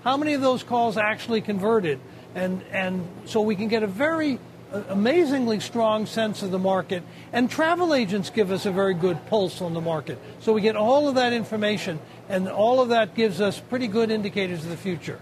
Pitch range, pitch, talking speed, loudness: 190-235 Hz, 215 Hz, 205 wpm, -24 LUFS